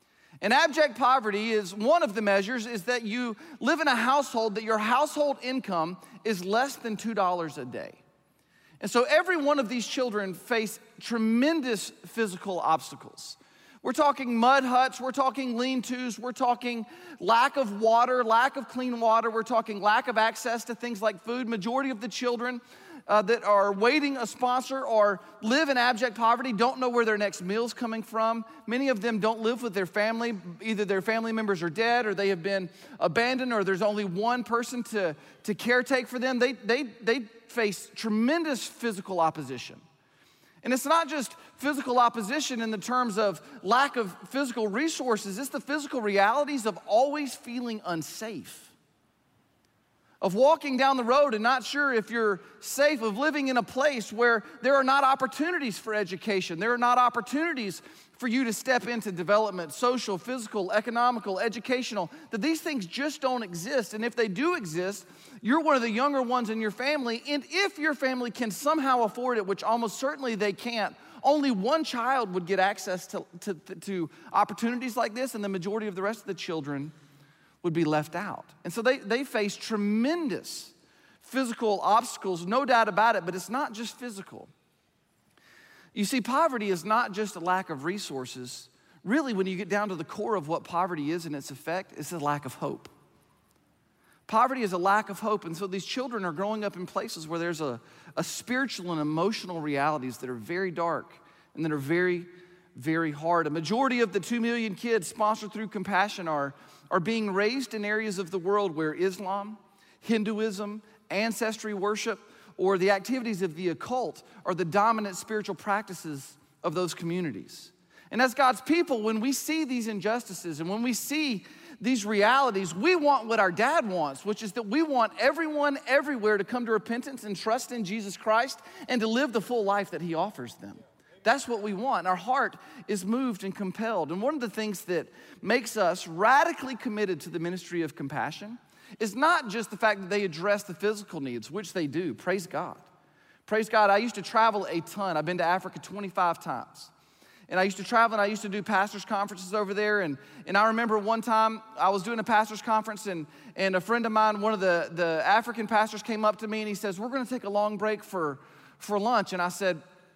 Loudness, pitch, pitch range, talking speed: -28 LUFS, 220 Hz, 195-250 Hz, 195 wpm